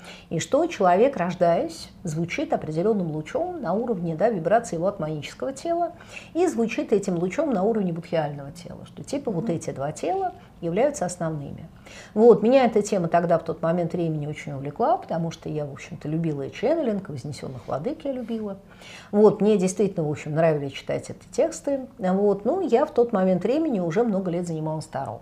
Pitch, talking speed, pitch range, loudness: 180 Hz, 180 wpm, 165-230 Hz, -24 LUFS